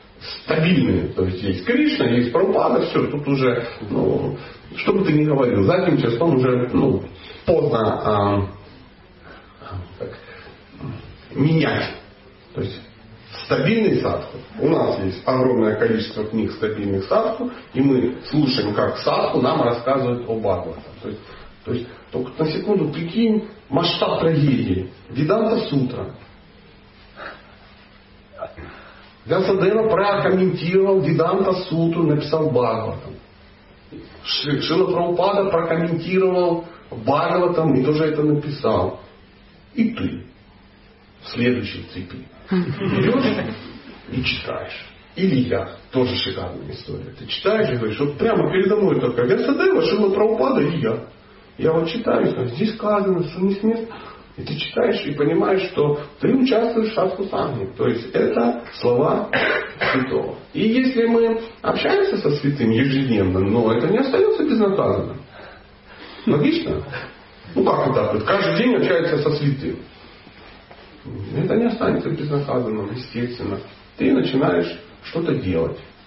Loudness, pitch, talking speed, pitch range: -20 LUFS, 145 Hz, 120 wpm, 115-190 Hz